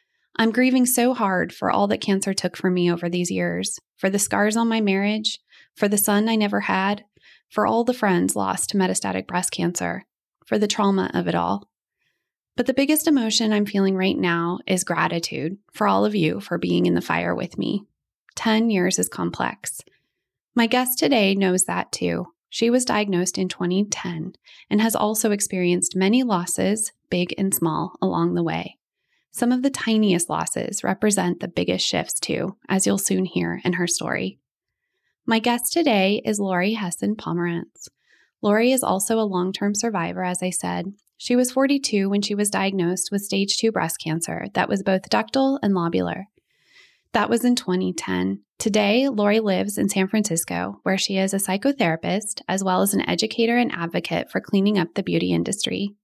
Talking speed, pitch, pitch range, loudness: 180 wpm, 195 Hz, 175-220 Hz, -22 LUFS